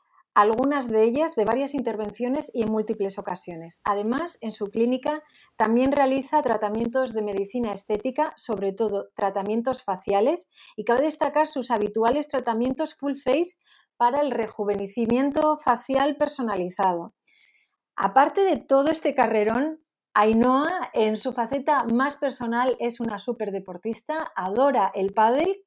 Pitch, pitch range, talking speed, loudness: 245 Hz, 215-285 Hz, 130 wpm, -24 LUFS